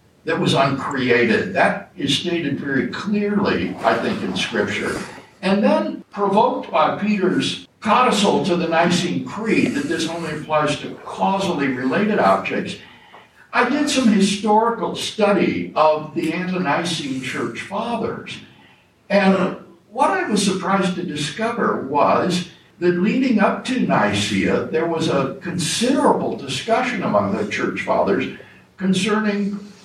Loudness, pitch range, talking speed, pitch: -19 LUFS, 165-210 Hz, 125 wpm, 190 Hz